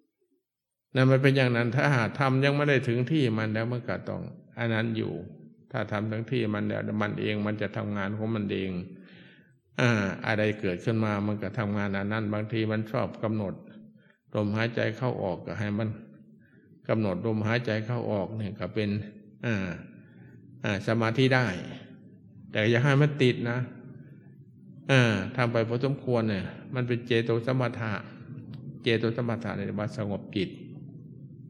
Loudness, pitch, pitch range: -28 LUFS, 115 Hz, 105-130 Hz